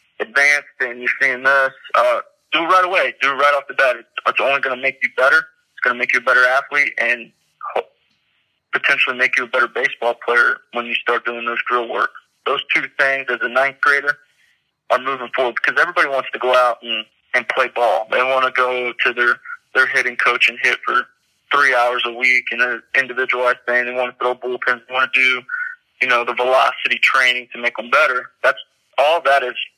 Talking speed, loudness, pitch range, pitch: 220 wpm, -17 LUFS, 125-145 Hz, 130 Hz